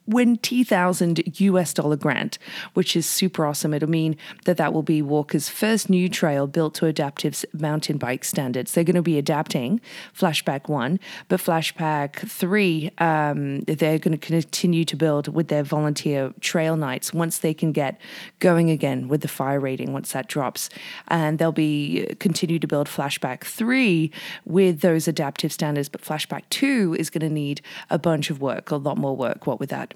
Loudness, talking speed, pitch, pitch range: -23 LUFS, 180 wpm, 160 Hz, 150-180 Hz